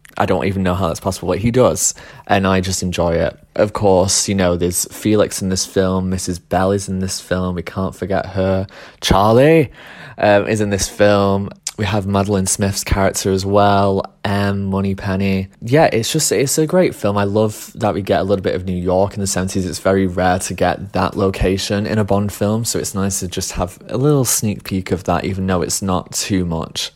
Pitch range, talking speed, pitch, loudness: 95-100 Hz, 220 wpm, 95 Hz, -17 LUFS